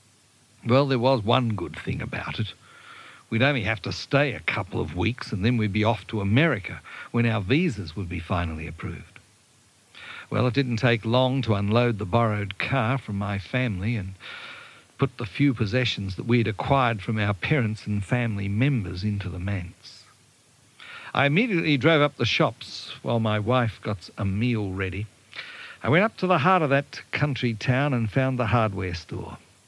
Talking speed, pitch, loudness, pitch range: 180 wpm, 115 Hz, -25 LUFS, 105-130 Hz